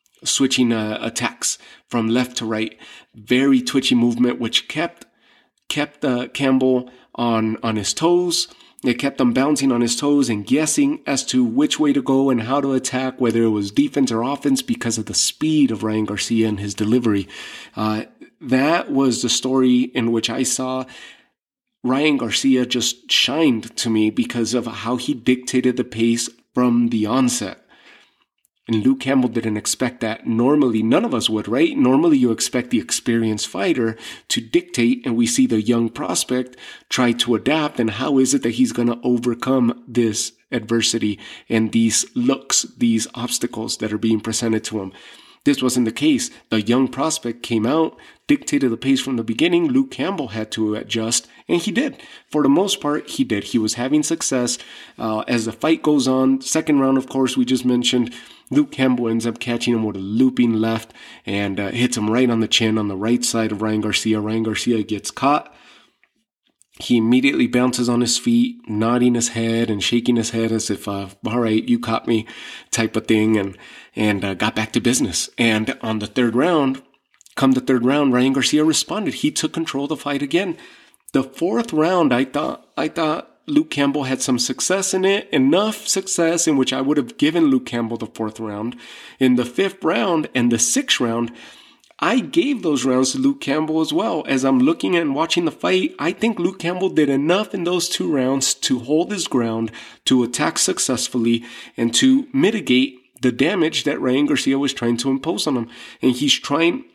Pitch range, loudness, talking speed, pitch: 115-145 Hz, -19 LUFS, 190 wpm, 125 Hz